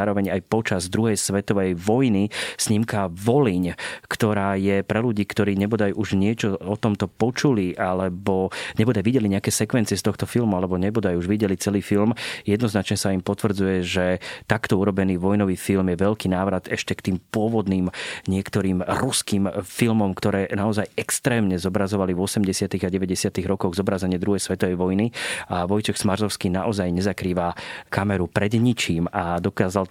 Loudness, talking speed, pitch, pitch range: -23 LUFS, 150 wpm, 100 Hz, 95-105 Hz